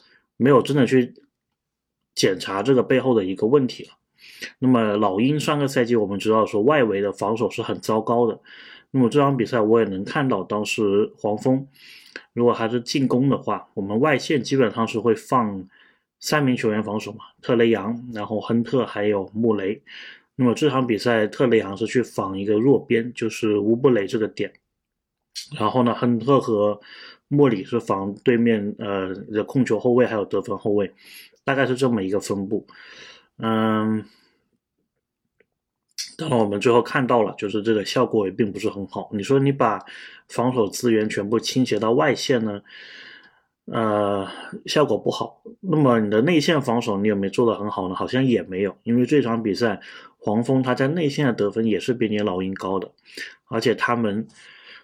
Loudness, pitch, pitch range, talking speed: -21 LUFS, 115 Hz, 105-125 Hz, 265 characters per minute